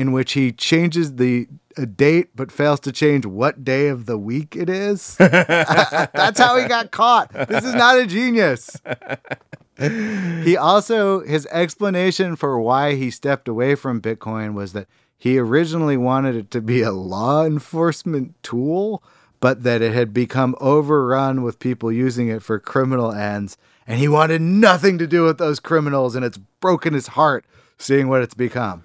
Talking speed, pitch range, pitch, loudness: 170 wpm, 125-170 Hz, 140 Hz, -18 LUFS